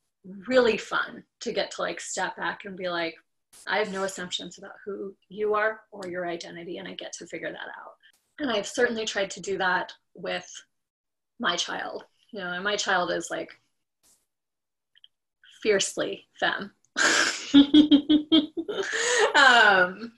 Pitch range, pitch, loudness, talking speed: 190-250 Hz, 205 Hz, -25 LUFS, 145 wpm